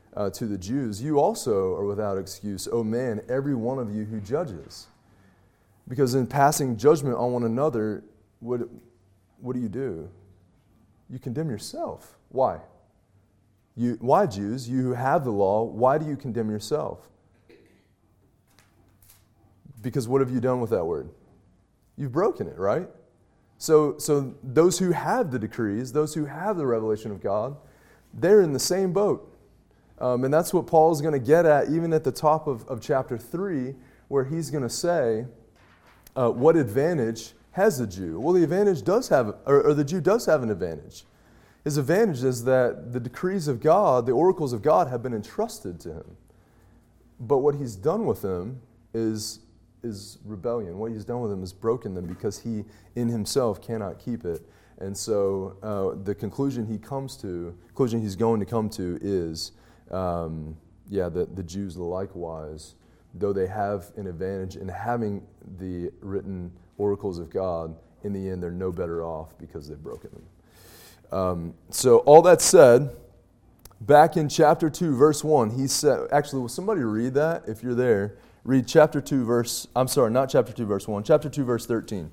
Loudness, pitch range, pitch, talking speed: -24 LUFS, 100-135 Hz, 115 Hz, 175 wpm